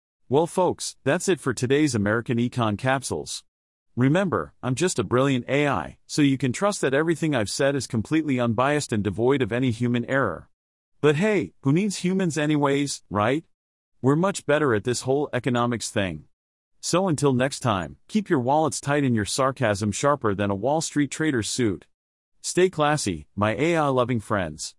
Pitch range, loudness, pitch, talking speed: 110-150 Hz, -24 LUFS, 130 Hz, 170 wpm